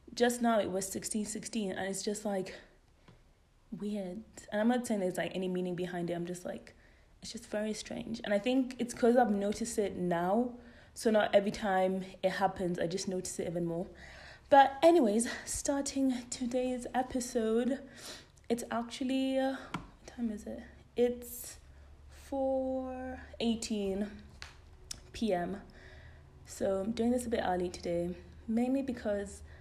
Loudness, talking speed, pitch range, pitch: -33 LUFS, 150 wpm, 185-245 Hz, 215 Hz